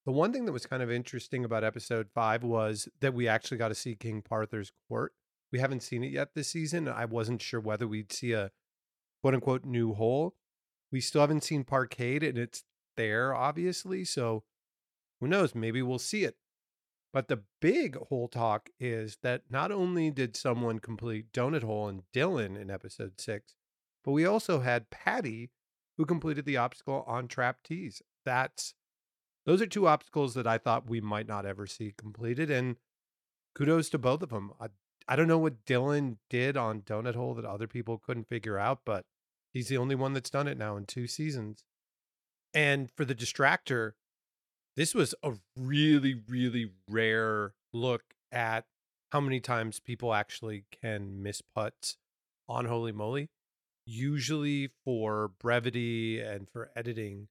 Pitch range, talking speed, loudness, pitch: 110-135 Hz, 170 wpm, -32 LUFS, 120 Hz